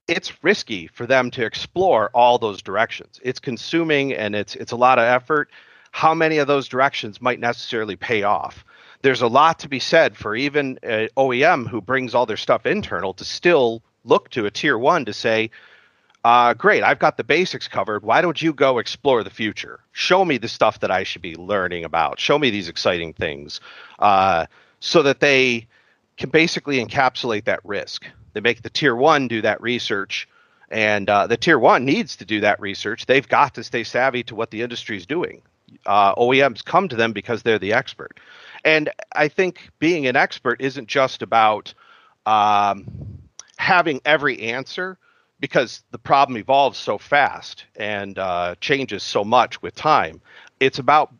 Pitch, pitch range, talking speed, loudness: 125 Hz, 110-145 Hz, 185 wpm, -19 LUFS